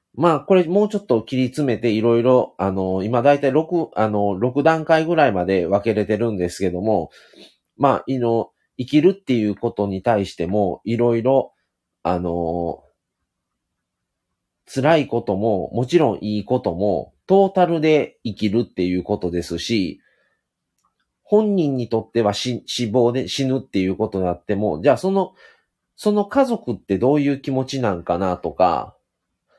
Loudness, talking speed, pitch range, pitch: -20 LUFS, 310 characters per minute, 95-145 Hz, 115 Hz